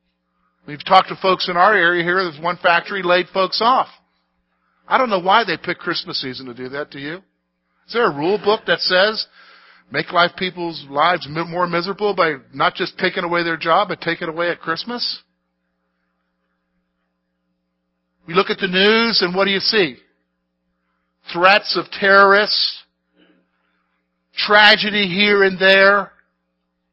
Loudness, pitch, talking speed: -16 LUFS, 170 Hz, 155 wpm